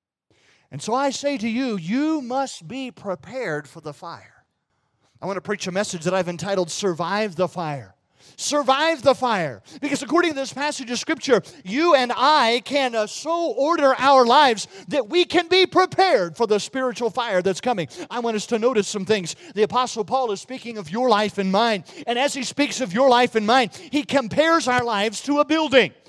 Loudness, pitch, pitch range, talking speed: -21 LUFS, 245 Hz, 200-275 Hz, 200 wpm